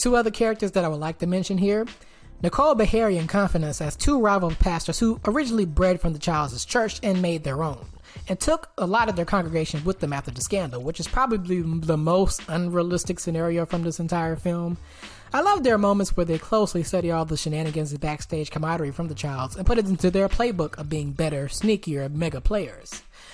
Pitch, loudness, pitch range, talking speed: 170 Hz, -24 LUFS, 160-200 Hz, 210 wpm